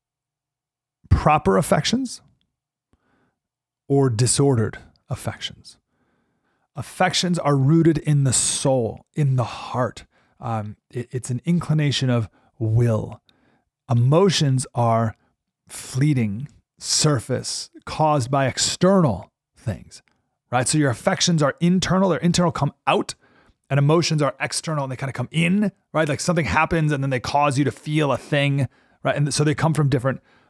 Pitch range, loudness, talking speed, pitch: 125-160 Hz, -21 LUFS, 135 wpm, 145 Hz